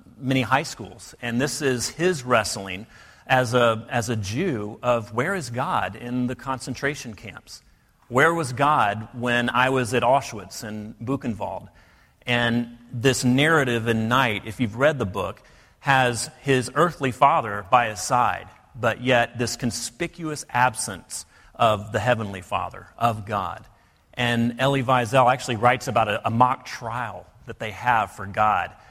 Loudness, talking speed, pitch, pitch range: -23 LUFS, 155 wpm, 120 Hz, 115-130 Hz